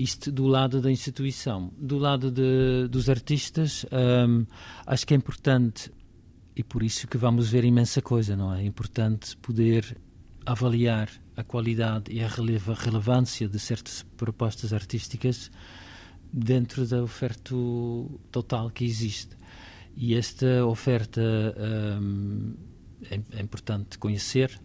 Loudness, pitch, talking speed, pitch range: -27 LUFS, 115 Hz, 130 wpm, 105-125 Hz